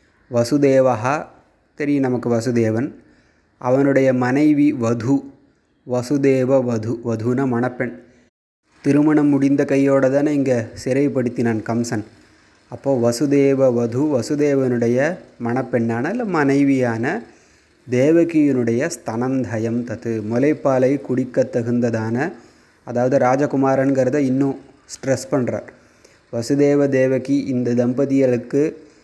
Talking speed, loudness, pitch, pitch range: 85 wpm, -19 LUFS, 130 Hz, 120-140 Hz